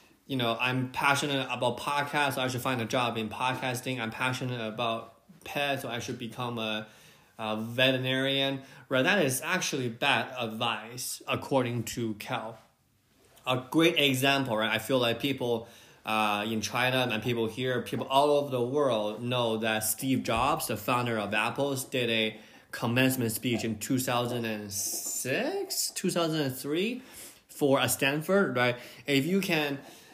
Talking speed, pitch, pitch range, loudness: 150 wpm, 125 Hz, 115-140 Hz, -29 LUFS